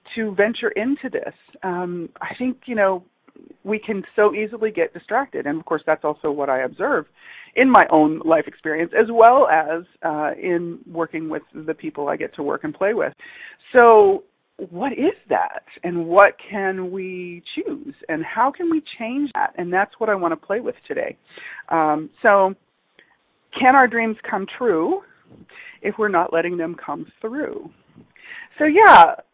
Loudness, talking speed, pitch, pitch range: -19 LUFS, 170 wpm, 205 Hz, 165-275 Hz